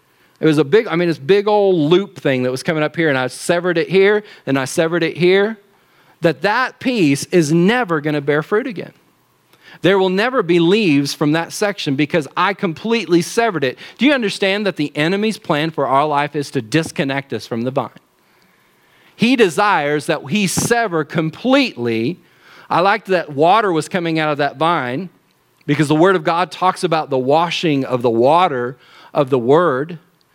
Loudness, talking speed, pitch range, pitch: -16 LUFS, 190 wpm, 145-190 Hz, 165 Hz